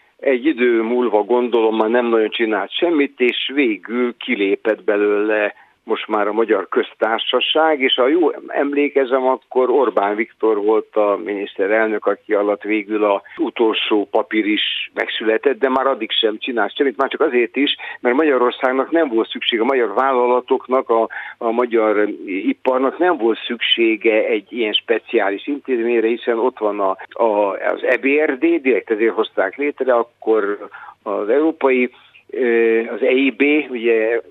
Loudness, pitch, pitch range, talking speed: -17 LUFS, 130 Hz, 115-155 Hz, 145 wpm